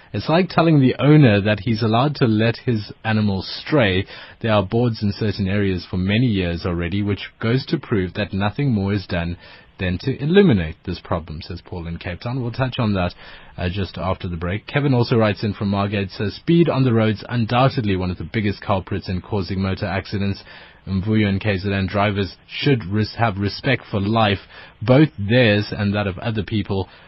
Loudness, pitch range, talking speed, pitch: -20 LUFS, 95-120 Hz, 195 wpm, 105 Hz